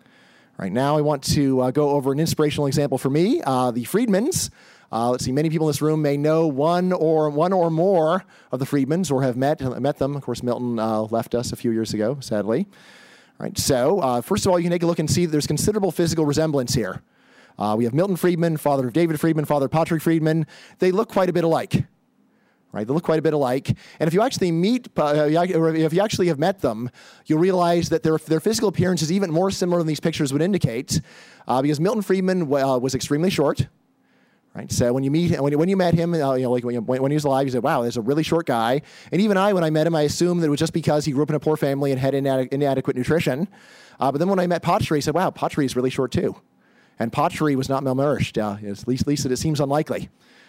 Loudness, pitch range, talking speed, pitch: -21 LUFS, 135-170 Hz, 260 wpm, 150 Hz